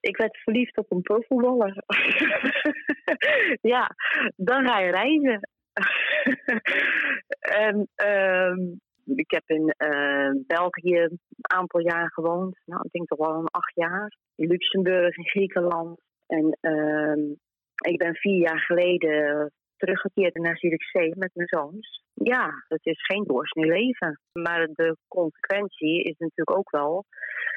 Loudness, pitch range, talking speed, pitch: -24 LUFS, 165-215 Hz, 135 wpm, 180 Hz